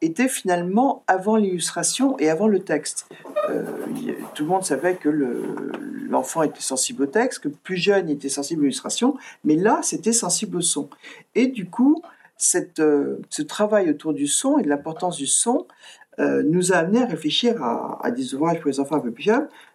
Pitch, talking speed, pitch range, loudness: 195 Hz, 195 wpm, 155-260 Hz, -22 LUFS